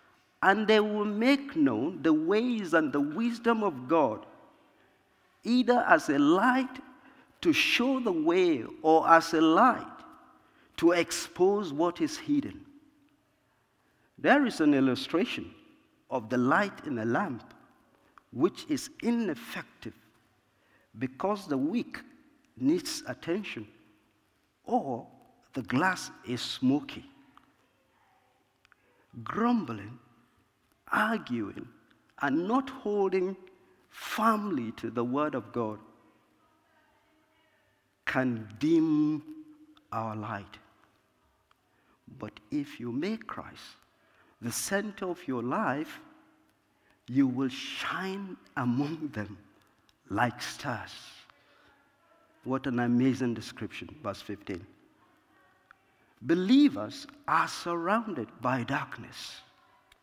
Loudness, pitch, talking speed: -29 LUFS, 210 Hz, 95 wpm